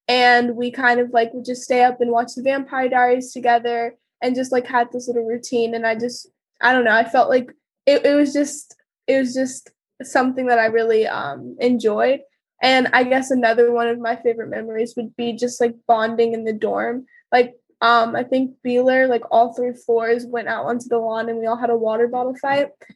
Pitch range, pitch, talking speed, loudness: 235-255 Hz, 245 Hz, 215 wpm, -19 LUFS